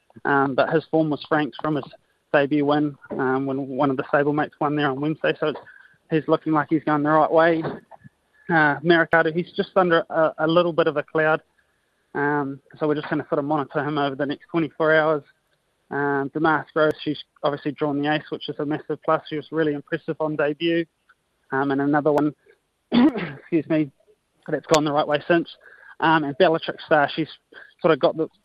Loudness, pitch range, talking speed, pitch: -22 LUFS, 145-160 Hz, 210 wpm, 155 Hz